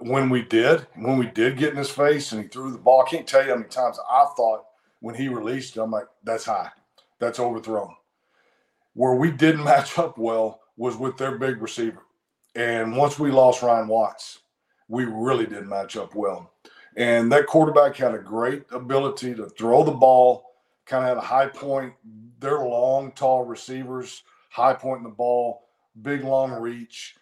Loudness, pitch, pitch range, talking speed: -22 LUFS, 125 Hz, 115-135 Hz, 190 wpm